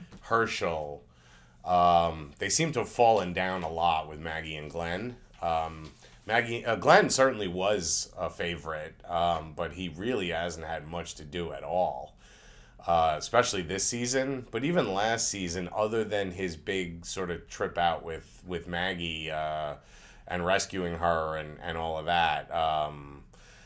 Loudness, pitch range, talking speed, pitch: -29 LUFS, 80-100 Hz, 155 wpm, 85 Hz